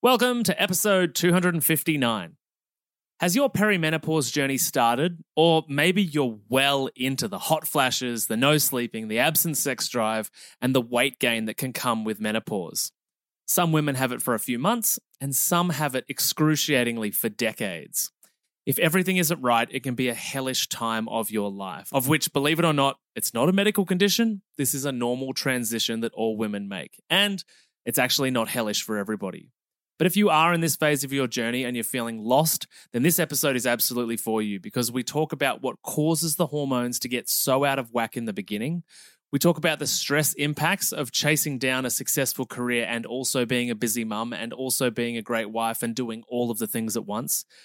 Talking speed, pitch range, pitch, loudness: 200 wpm, 120-160 Hz, 135 Hz, -24 LUFS